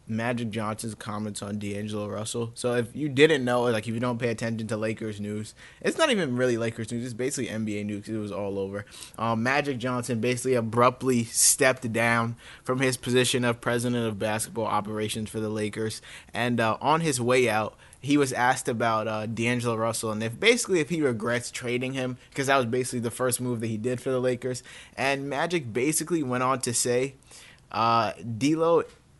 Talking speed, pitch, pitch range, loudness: 195 wpm, 120 Hz, 110-125 Hz, -26 LUFS